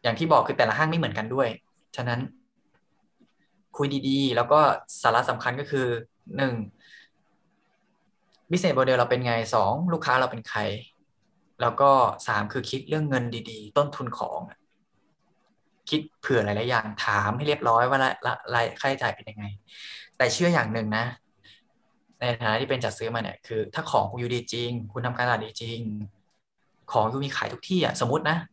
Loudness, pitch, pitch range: -25 LUFS, 125 Hz, 115-140 Hz